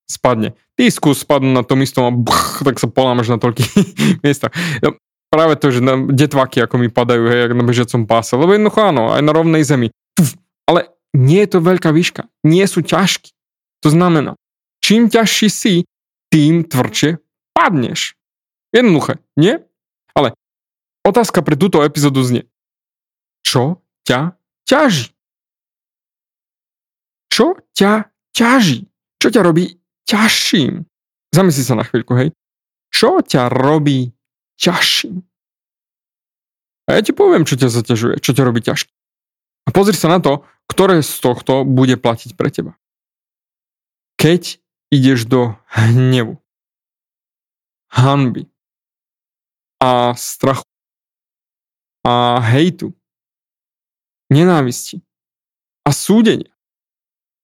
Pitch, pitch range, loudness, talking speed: 145 Hz, 125-175 Hz, -14 LUFS, 110 wpm